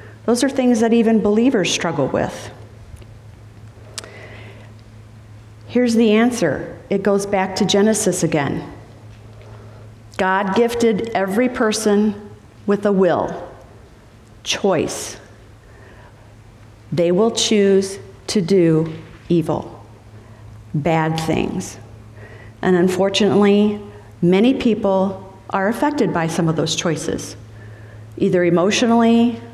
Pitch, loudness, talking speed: 160 Hz, -18 LUFS, 95 wpm